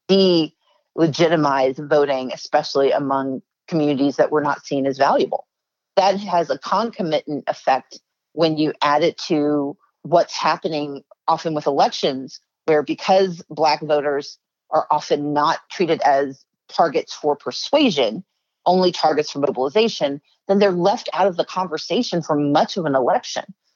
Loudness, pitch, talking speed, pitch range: -20 LUFS, 155 Hz, 135 wpm, 145-180 Hz